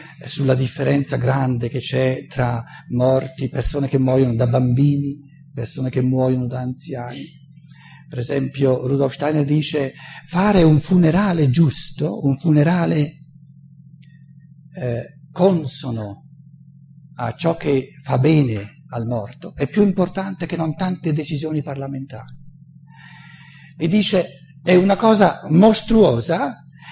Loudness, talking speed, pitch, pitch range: -19 LUFS, 115 wpm, 145 Hz, 130-155 Hz